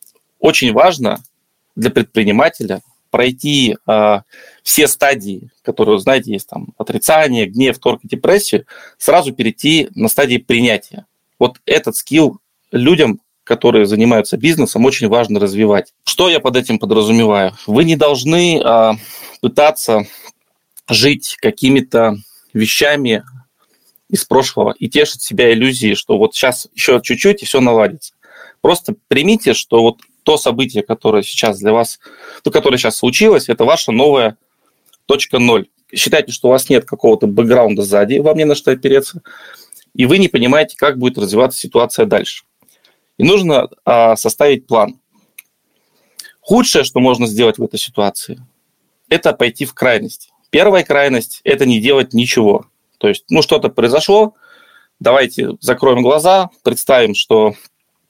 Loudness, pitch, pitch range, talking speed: -12 LUFS, 125 Hz, 110-155 Hz, 135 wpm